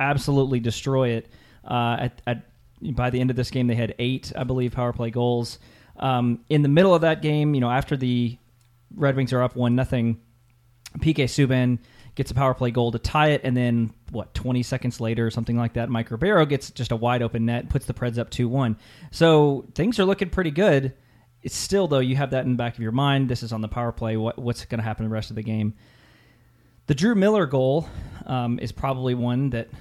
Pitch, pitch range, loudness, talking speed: 125 Hz, 120-135 Hz, -23 LUFS, 230 wpm